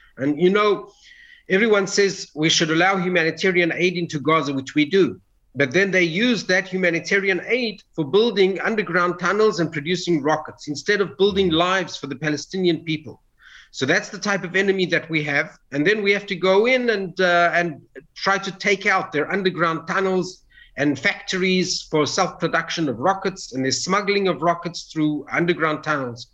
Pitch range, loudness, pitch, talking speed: 160-195 Hz, -20 LUFS, 180 Hz, 180 wpm